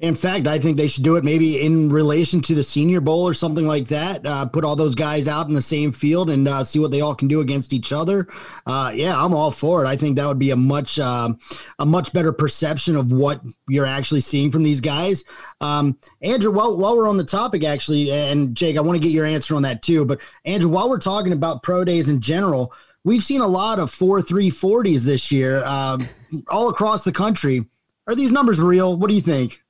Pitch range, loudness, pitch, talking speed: 145-180 Hz, -19 LUFS, 155 Hz, 240 wpm